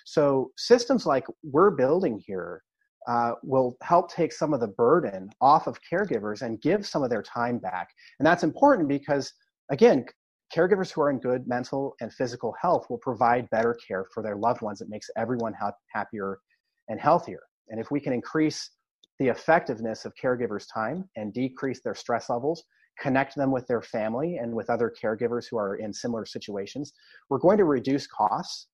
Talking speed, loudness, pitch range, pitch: 180 wpm, -26 LUFS, 115-150 Hz, 130 Hz